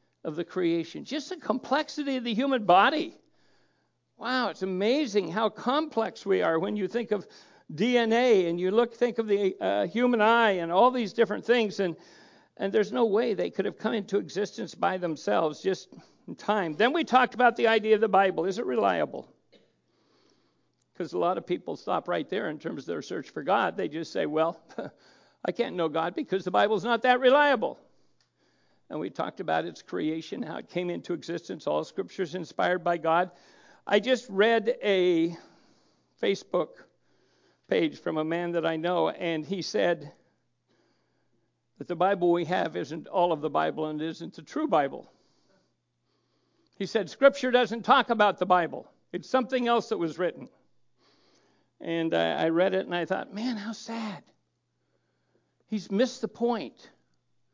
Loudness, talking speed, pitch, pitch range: -27 LUFS, 175 wpm, 200 Hz, 170-235 Hz